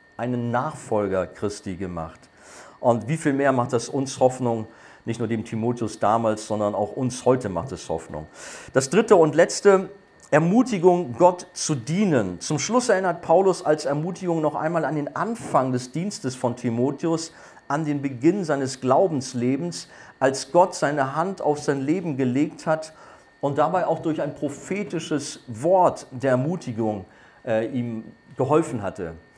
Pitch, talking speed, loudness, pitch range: 140 Hz, 150 wpm, -23 LUFS, 120-165 Hz